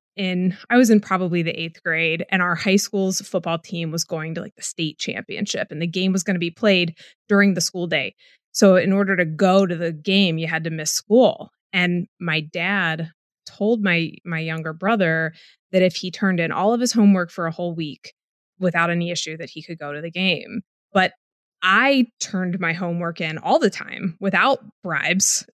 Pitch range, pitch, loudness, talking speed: 165-195 Hz, 180 Hz, -20 LUFS, 205 wpm